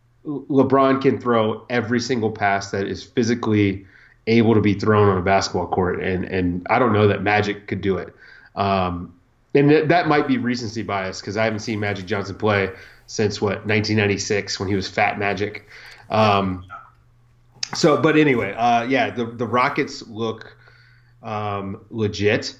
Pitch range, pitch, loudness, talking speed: 100-120 Hz, 110 Hz, -20 LUFS, 165 wpm